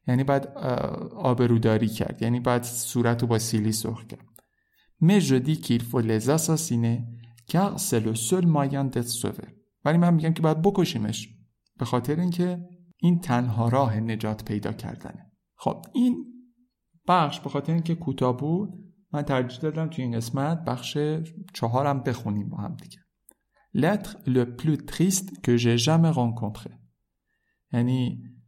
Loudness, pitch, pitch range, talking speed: -25 LUFS, 130 Hz, 115-165 Hz, 140 wpm